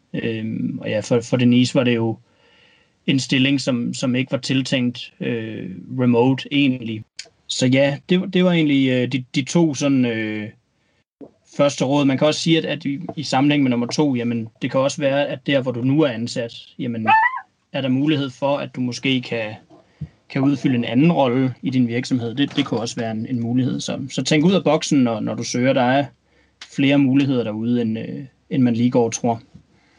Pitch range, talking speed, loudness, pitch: 120-140 Hz, 210 wpm, -20 LUFS, 130 Hz